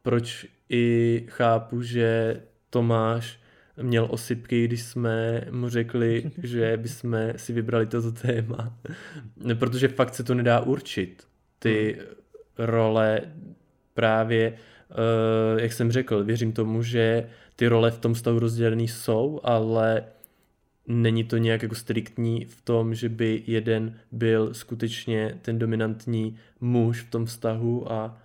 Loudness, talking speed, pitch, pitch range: -25 LUFS, 125 wpm, 115 Hz, 115-120 Hz